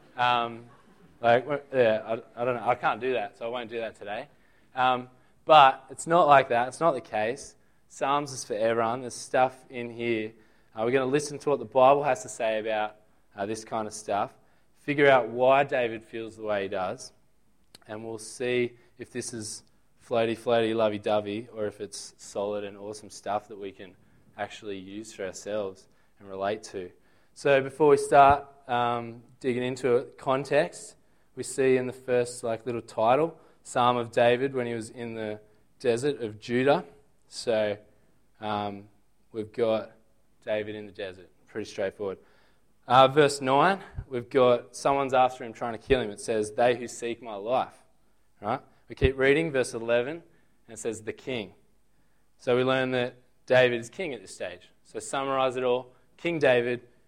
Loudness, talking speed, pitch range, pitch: -27 LUFS, 180 wpm, 110-130 Hz, 120 Hz